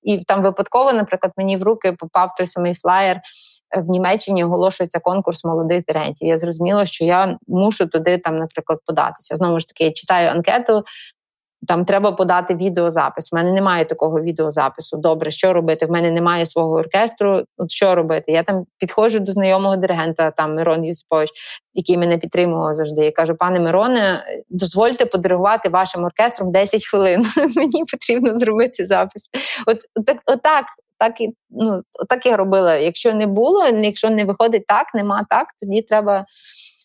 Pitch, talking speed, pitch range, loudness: 185 Hz, 160 wpm, 170-215 Hz, -17 LUFS